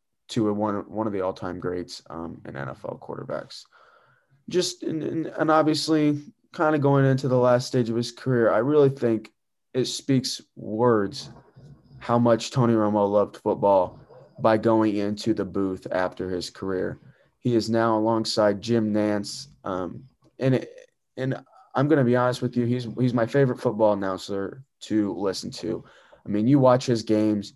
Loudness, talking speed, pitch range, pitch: -24 LUFS, 175 wpm, 105-130 Hz, 115 Hz